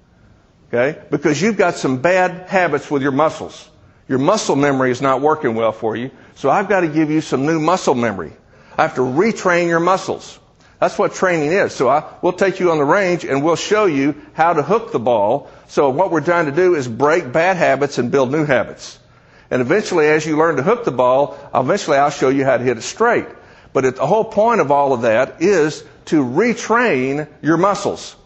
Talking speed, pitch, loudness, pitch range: 215 wpm, 155 Hz, -16 LUFS, 140-180 Hz